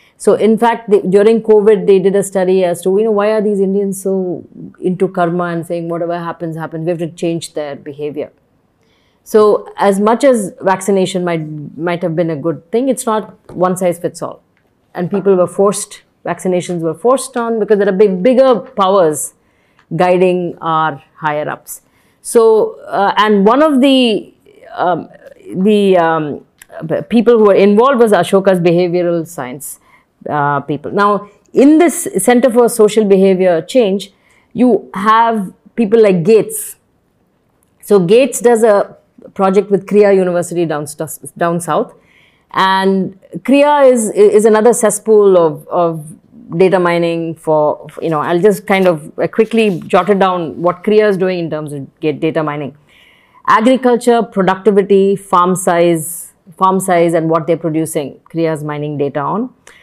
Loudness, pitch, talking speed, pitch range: -12 LUFS, 190 Hz, 160 wpm, 170-215 Hz